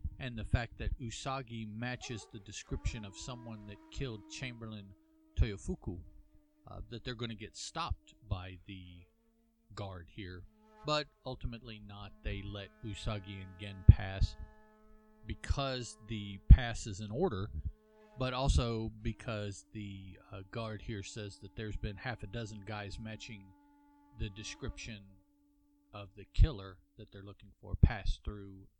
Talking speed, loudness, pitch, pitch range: 140 wpm, -38 LUFS, 105 Hz, 100-120 Hz